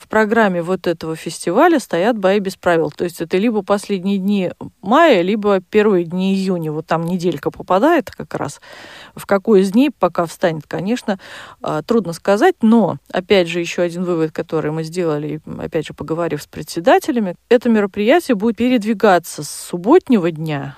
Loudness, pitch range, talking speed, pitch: -17 LUFS, 170-220 Hz, 160 wpm, 185 Hz